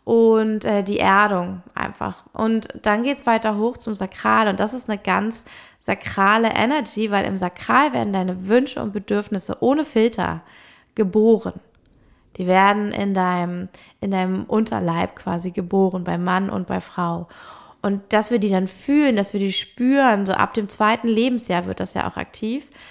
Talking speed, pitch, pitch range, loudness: 170 wpm, 205 Hz, 185-225 Hz, -20 LUFS